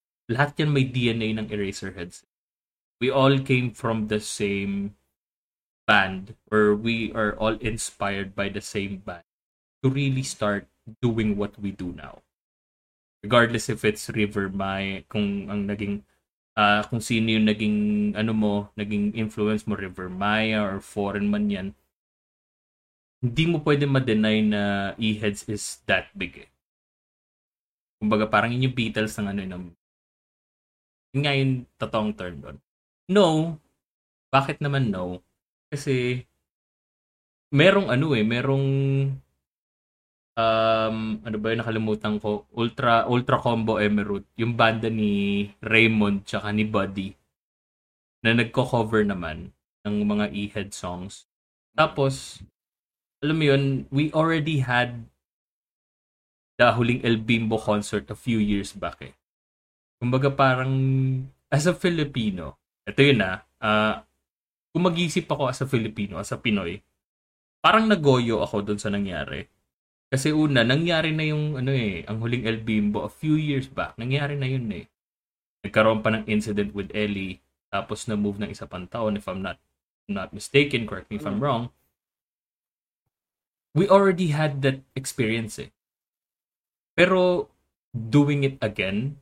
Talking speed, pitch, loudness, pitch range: 135 wpm, 110 Hz, -24 LUFS, 100-130 Hz